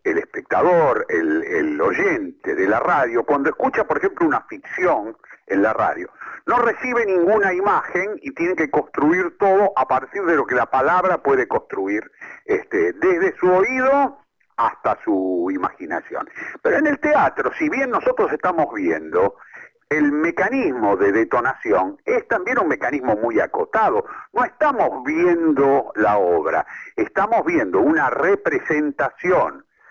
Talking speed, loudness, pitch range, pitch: 140 wpm, -19 LUFS, 300-415 Hz, 355 Hz